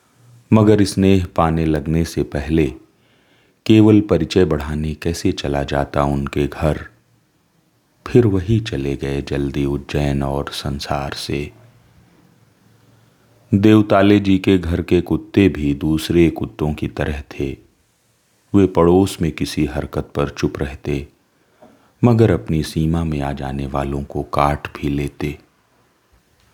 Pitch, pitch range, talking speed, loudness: 80 Hz, 70-100 Hz, 120 wpm, -18 LUFS